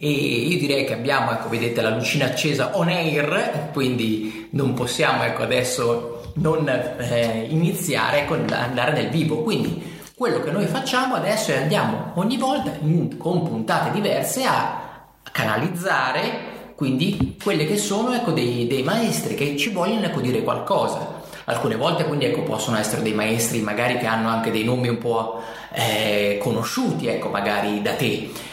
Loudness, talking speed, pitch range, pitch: -22 LUFS, 160 wpm, 115-170 Hz, 140 Hz